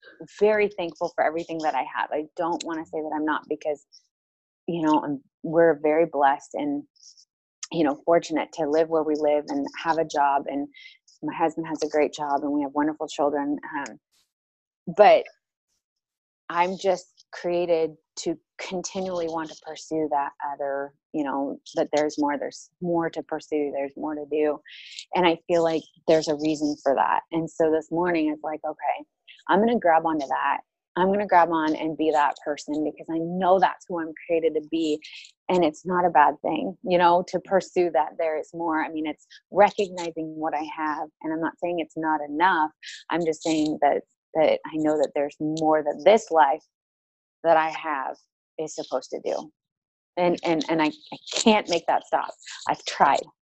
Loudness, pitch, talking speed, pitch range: -25 LUFS, 160 Hz, 190 wpm, 150-175 Hz